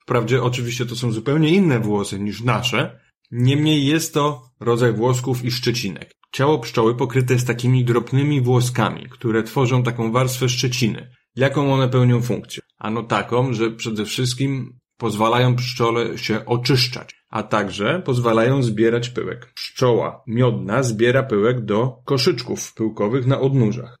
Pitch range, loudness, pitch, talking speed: 115-130 Hz, -20 LUFS, 125 Hz, 140 wpm